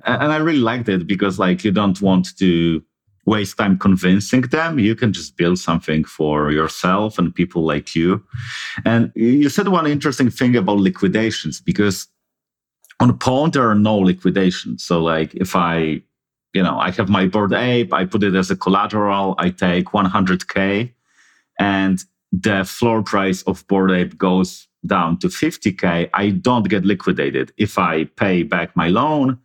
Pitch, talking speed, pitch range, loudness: 95 Hz, 175 wpm, 90-110 Hz, -17 LUFS